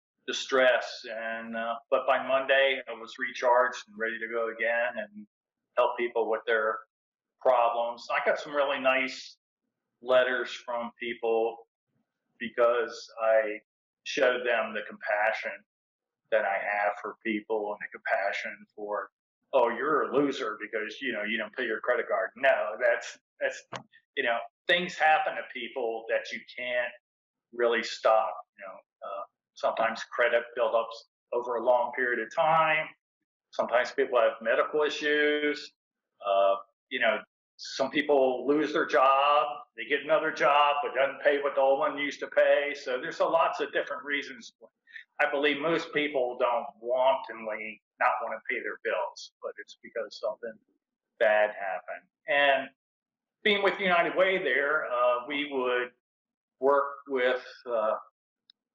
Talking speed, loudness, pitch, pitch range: 150 wpm, -28 LUFS, 130 Hz, 115-150 Hz